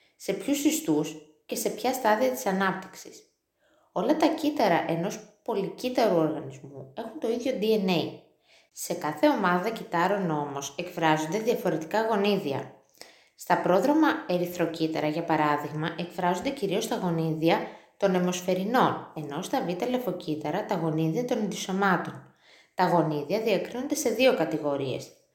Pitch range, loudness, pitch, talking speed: 160-230 Hz, -27 LUFS, 190 Hz, 125 wpm